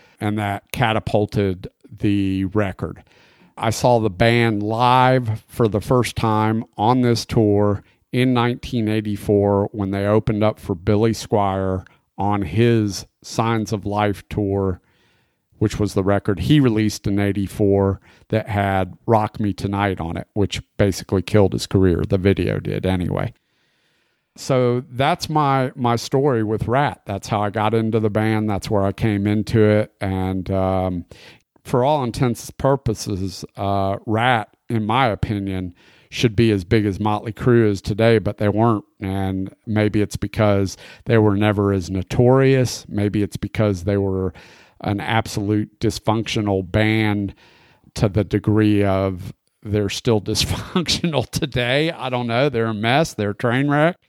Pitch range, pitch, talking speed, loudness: 100-115 Hz, 105 Hz, 150 wpm, -20 LUFS